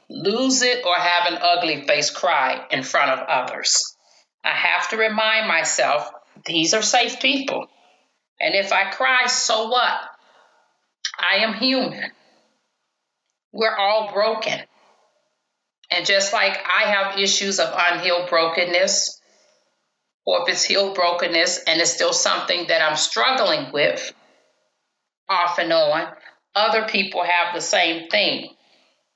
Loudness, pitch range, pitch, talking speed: -19 LUFS, 175-250 Hz, 200 Hz, 130 wpm